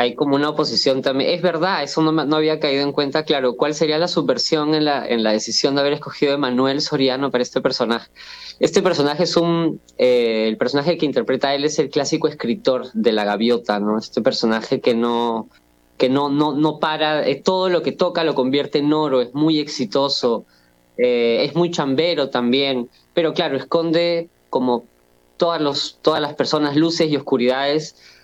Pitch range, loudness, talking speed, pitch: 125-155 Hz, -19 LUFS, 190 wpm, 145 Hz